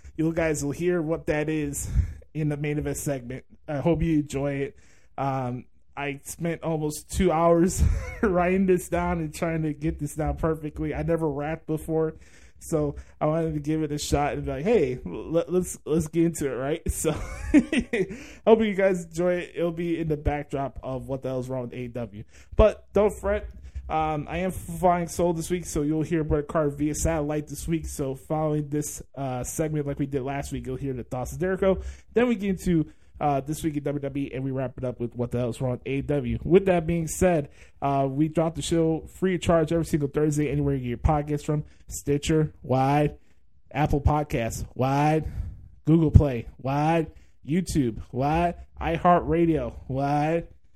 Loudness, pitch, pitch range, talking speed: -26 LUFS, 150 Hz, 135-165 Hz, 195 wpm